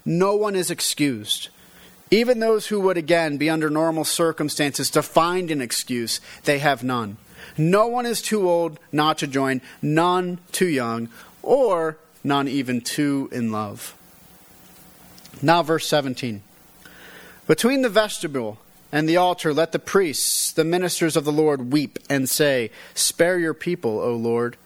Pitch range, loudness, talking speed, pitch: 135-175 Hz, -21 LUFS, 150 wpm, 155 Hz